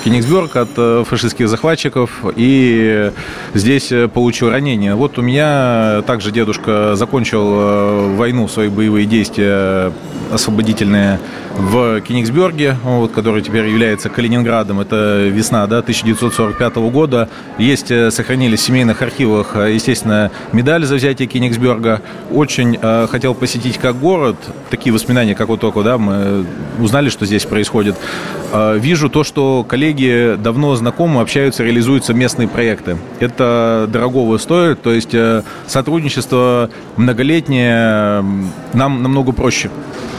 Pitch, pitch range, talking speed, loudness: 115 Hz, 110-125 Hz, 115 wpm, -13 LUFS